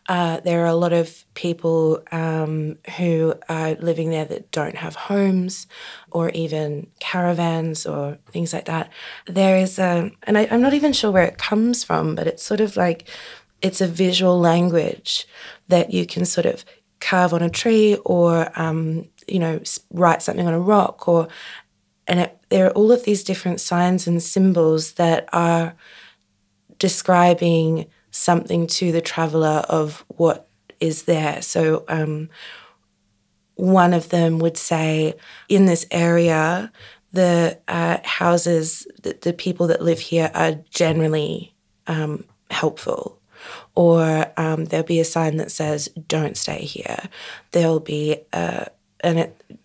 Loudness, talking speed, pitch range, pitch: -19 LUFS, 150 wpm, 160-180 Hz, 170 Hz